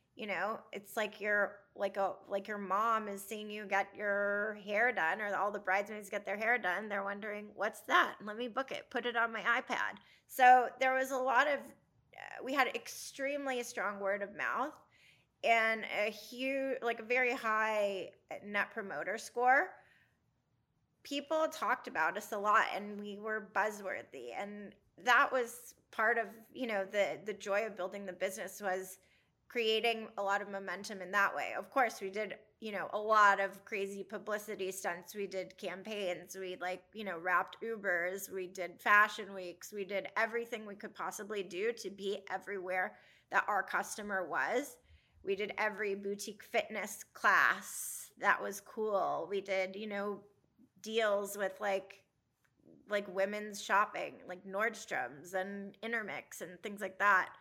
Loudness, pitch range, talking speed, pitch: -35 LUFS, 195-220 Hz, 165 wpm, 205 Hz